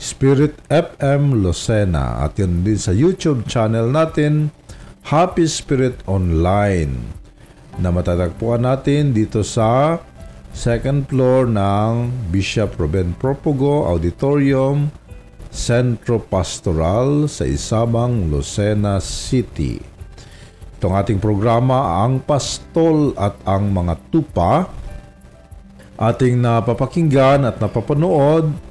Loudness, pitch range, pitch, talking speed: -17 LUFS, 95-140 Hz, 115 Hz, 90 wpm